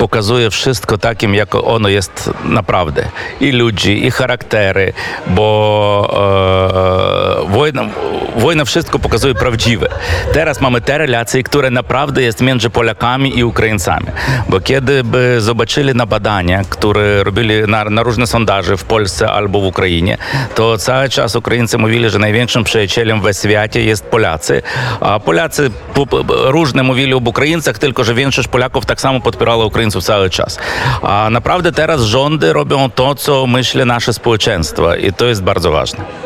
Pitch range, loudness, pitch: 105-130 Hz, -12 LUFS, 120 Hz